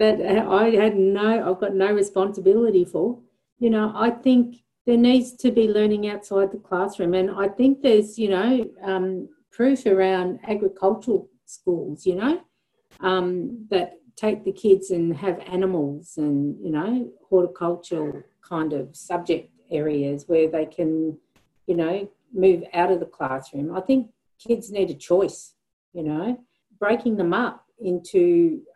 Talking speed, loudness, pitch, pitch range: 150 wpm, -22 LUFS, 190 Hz, 175-220 Hz